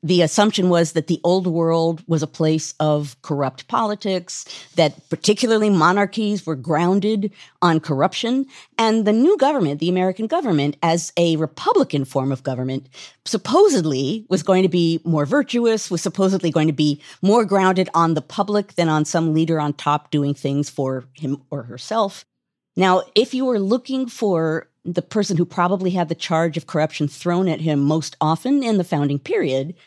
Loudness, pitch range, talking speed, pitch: -19 LUFS, 155-200 Hz, 175 wpm, 170 Hz